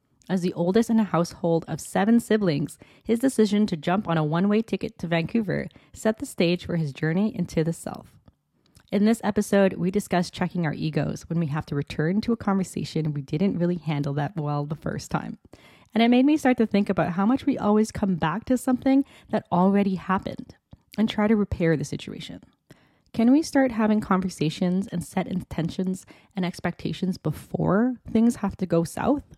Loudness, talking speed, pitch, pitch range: -25 LUFS, 195 wpm, 190 Hz, 165-220 Hz